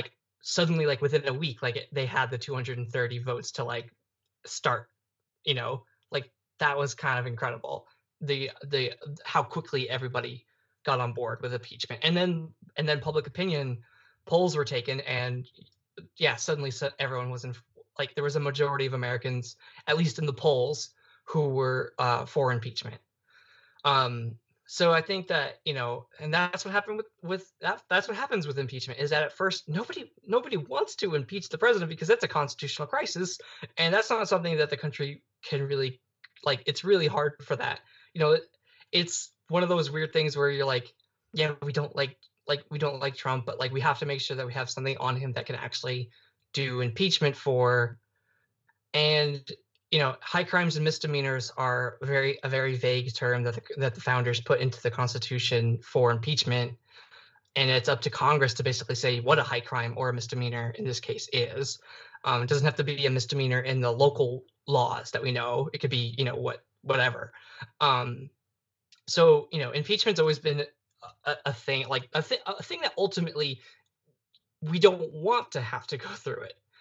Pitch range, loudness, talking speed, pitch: 125-155 Hz, -28 LUFS, 190 wpm, 140 Hz